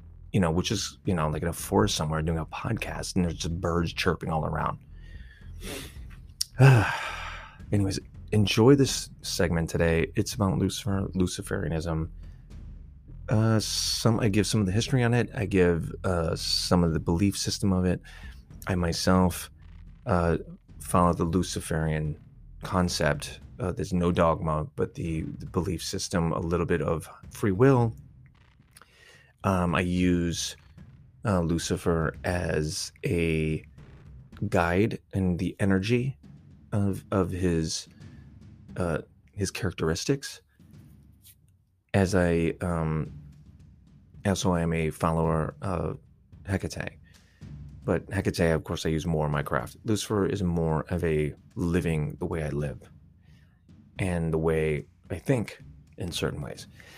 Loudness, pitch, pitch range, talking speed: -27 LUFS, 85 Hz, 80-95 Hz, 135 wpm